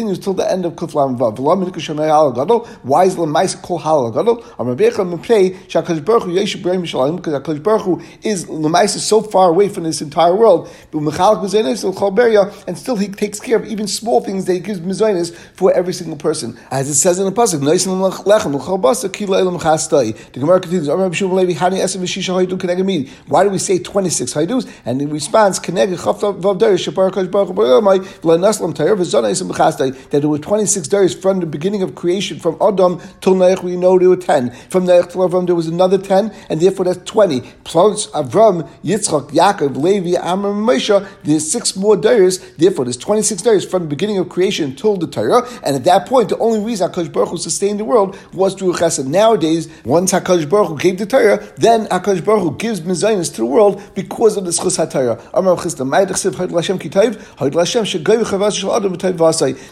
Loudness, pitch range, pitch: -15 LUFS, 170-200 Hz, 185 Hz